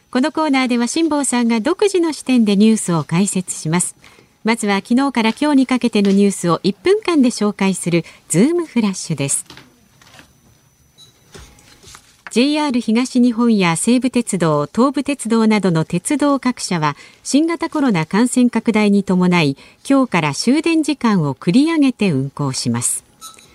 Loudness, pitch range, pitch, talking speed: -16 LUFS, 180-270 Hz, 230 Hz, 300 characters per minute